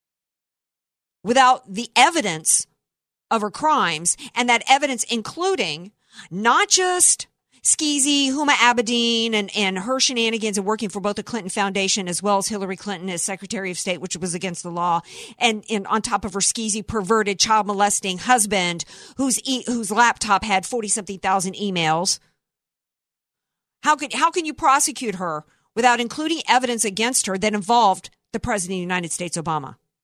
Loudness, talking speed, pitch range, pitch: -20 LUFS, 160 wpm, 190-245 Hz, 215 Hz